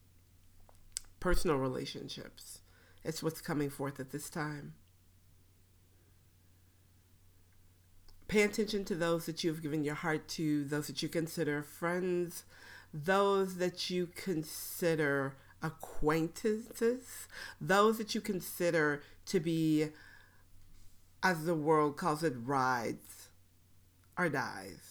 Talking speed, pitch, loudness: 105 wpm, 150 Hz, -35 LUFS